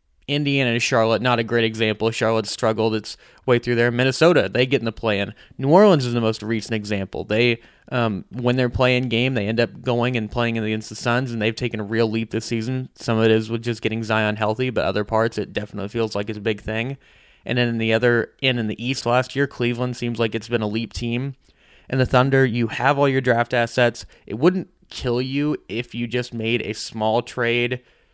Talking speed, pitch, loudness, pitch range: 230 wpm, 120 Hz, -21 LUFS, 110-125 Hz